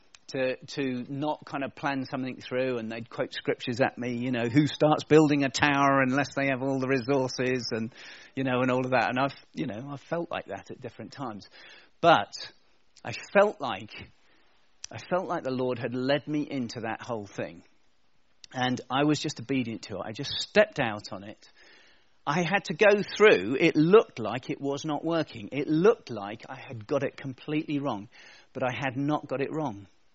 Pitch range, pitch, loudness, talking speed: 125-150 Hz, 135 Hz, -27 LUFS, 205 wpm